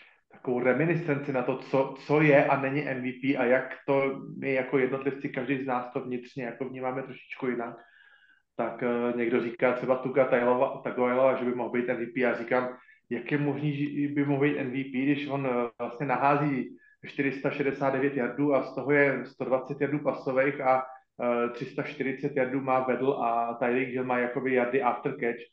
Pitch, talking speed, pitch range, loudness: 130 Hz, 175 wpm, 125-140 Hz, -28 LUFS